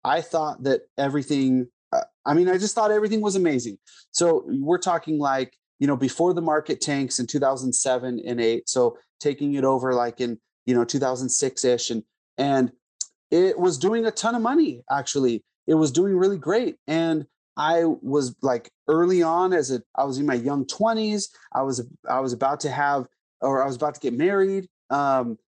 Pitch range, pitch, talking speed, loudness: 130-180 Hz, 145 Hz, 190 wpm, -23 LUFS